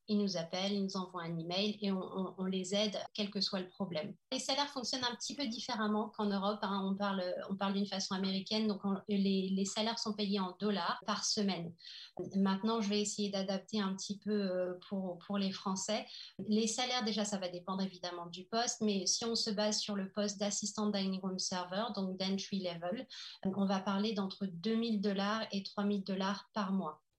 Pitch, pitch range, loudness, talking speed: 200 Hz, 190-210 Hz, -36 LUFS, 210 wpm